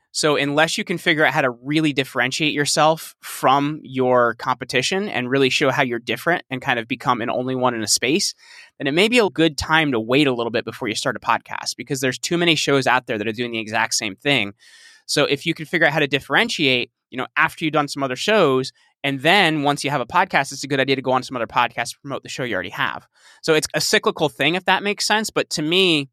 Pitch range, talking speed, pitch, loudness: 130-160 Hz, 260 wpm, 140 Hz, -19 LUFS